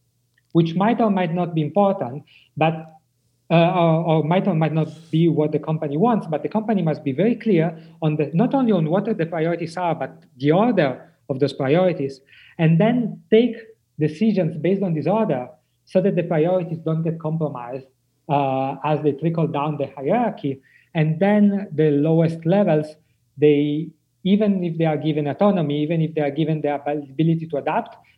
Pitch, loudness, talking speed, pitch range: 160 Hz, -21 LUFS, 180 wpm, 145-185 Hz